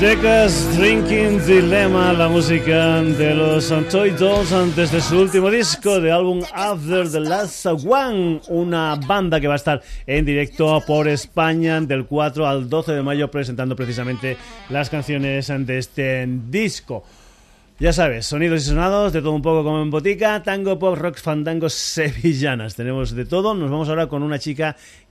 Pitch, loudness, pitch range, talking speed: 160 Hz, -18 LUFS, 145-180 Hz, 165 wpm